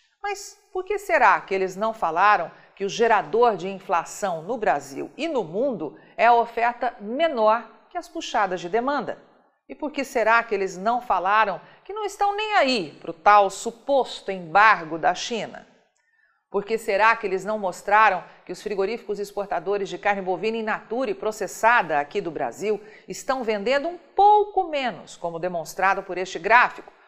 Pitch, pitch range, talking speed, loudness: 220 Hz, 195-265 Hz, 175 wpm, -23 LUFS